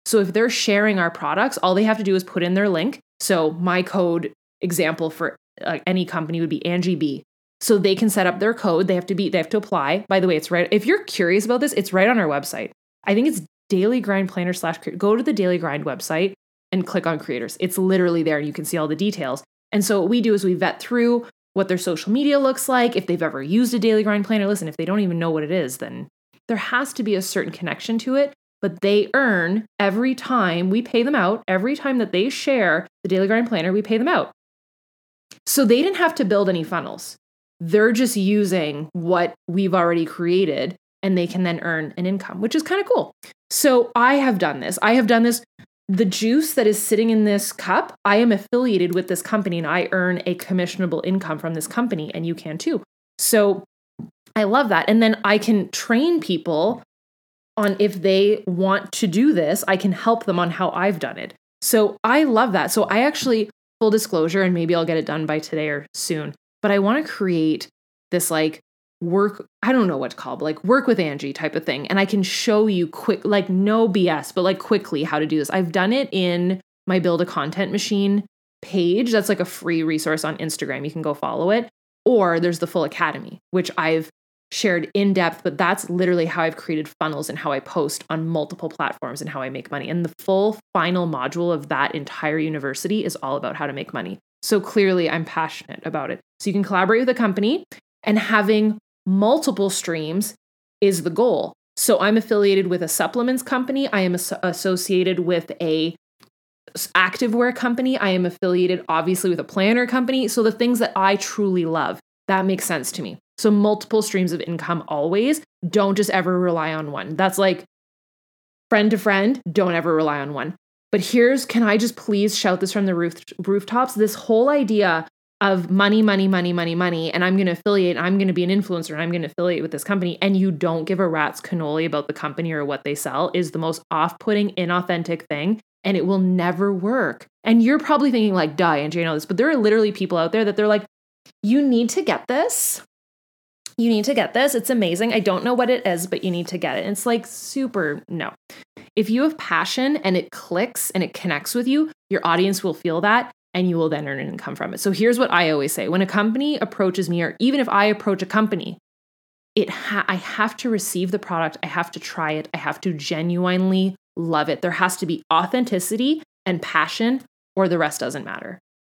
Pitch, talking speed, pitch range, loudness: 190 Hz, 225 wpm, 170-215 Hz, -20 LUFS